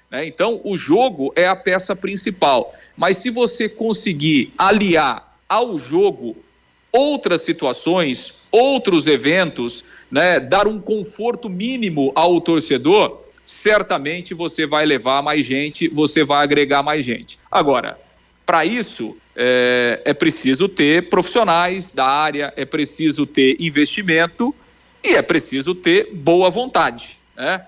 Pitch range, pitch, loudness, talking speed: 150-215 Hz, 175 Hz, -17 LUFS, 125 wpm